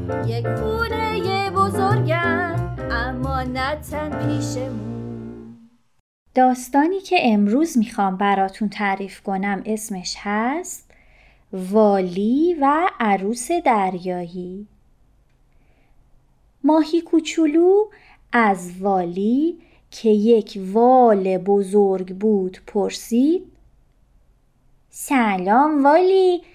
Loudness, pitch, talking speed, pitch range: -19 LUFS, 210 Hz, 60 wpm, 185-290 Hz